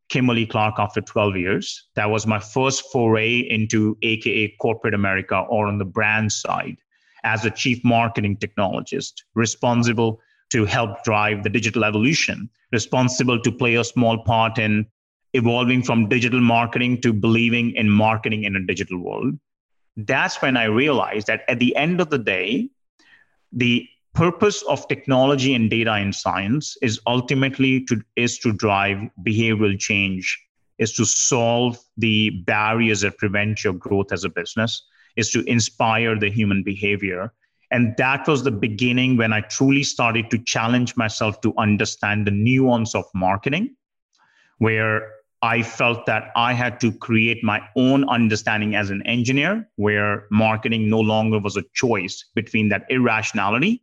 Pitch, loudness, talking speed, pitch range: 115 Hz, -20 LUFS, 155 wpm, 105-125 Hz